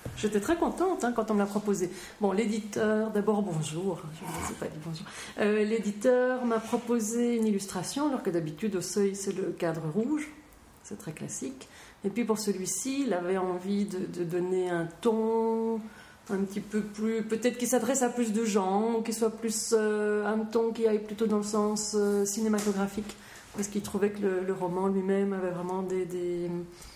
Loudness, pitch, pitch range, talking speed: -30 LUFS, 210 Hz, 190-225 Hz, 195 wpm